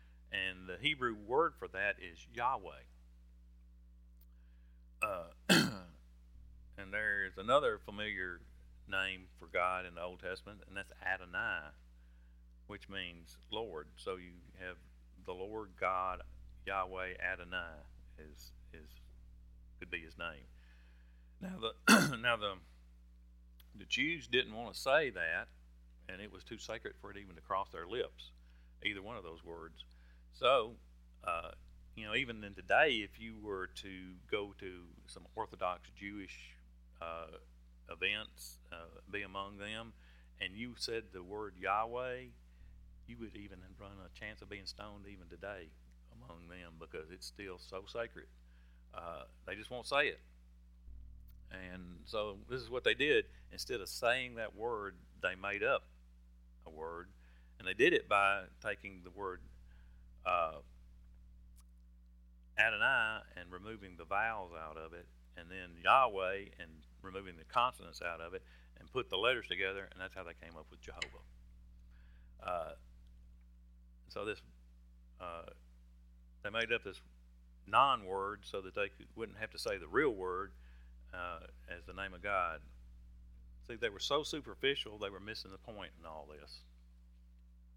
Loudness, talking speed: -38 LUFS, 150 wpm